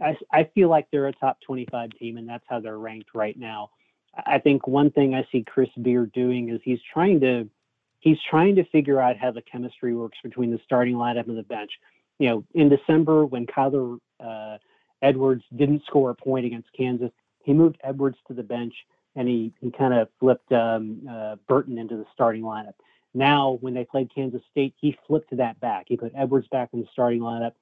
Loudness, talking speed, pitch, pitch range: -23 LUFS, 205 wpm, 125 Hz, 115-135 Hz